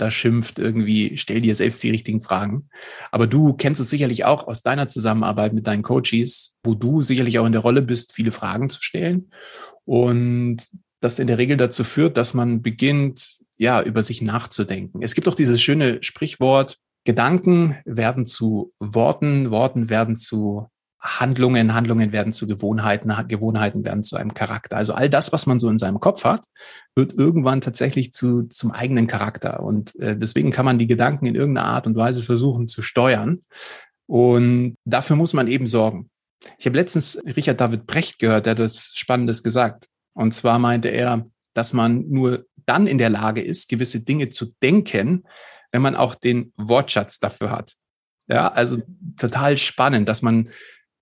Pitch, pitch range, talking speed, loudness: 120 Hz, 115-130 Hz, 175 wpm, -20 LUFS